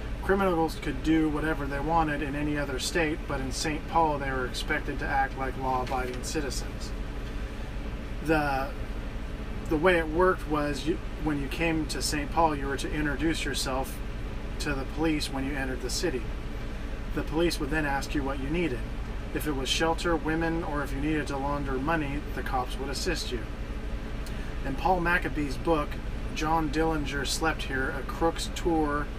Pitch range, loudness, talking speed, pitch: 135-160 Hz, -30 LUFS, 175 wpm, 145 Hz